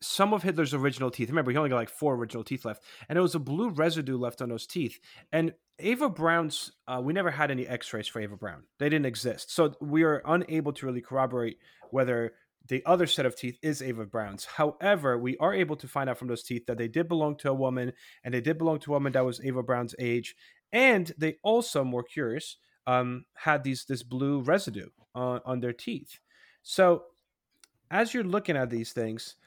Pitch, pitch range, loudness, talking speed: 135 Hz, 125-160 Hz, -29 LUFS, 215 wpm